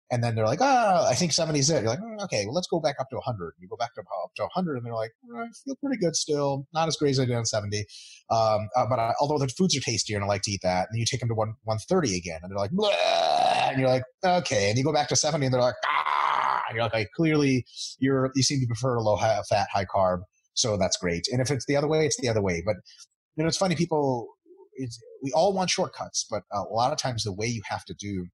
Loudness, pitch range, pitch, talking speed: -26 LUFS, 110-165 Hz, 130 Hz, 290 wpm